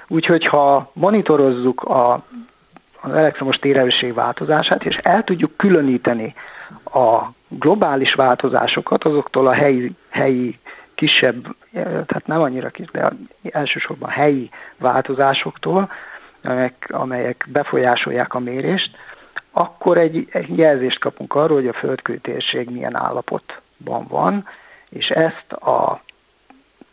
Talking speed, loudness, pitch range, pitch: 110 wpm, -18 LUFS, 130-160 Hz, 140 Hz